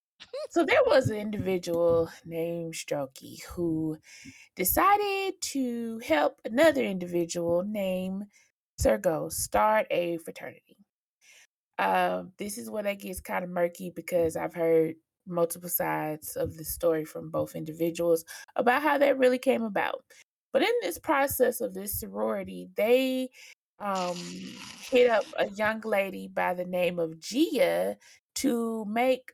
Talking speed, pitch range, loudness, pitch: 135 wpm, 165-255 Hz, -28 LUFS, 190 Hz